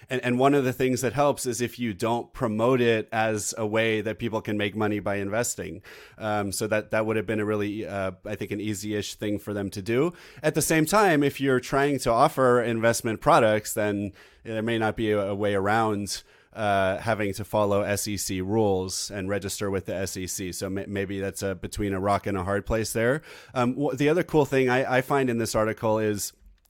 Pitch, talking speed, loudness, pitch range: 110 Hz, 220 wpm, -26 LUFS, 100-120 Hz